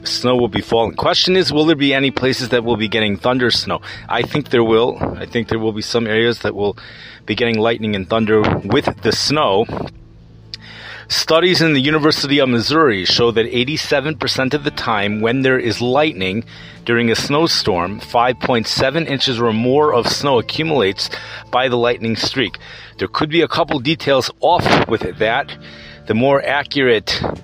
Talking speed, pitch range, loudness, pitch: 175 wpm, 110-145 Hz, -16 LUFS, 120 Hz